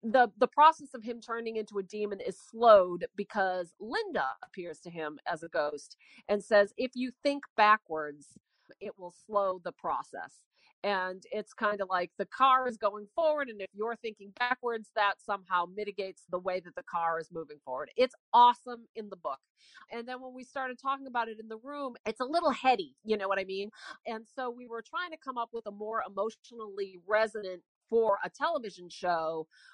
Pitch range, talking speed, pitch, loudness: 190-250 Hz, 200 wpm, 215 Hz, -31 LUFS